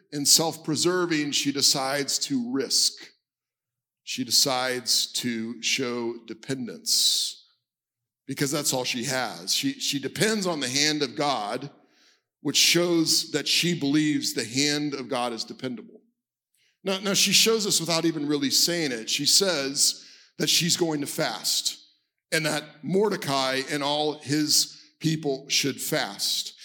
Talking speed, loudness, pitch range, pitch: 140 wpm, -23 LUFS, 135-165 Hz, 150 Hz